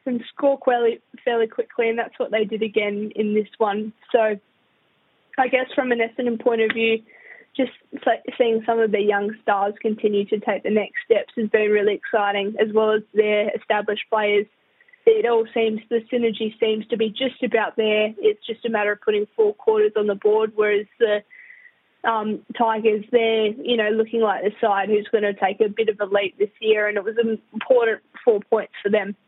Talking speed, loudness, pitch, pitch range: 205 wpm, -21 LUFS, 220 Hz, 210-240 Hz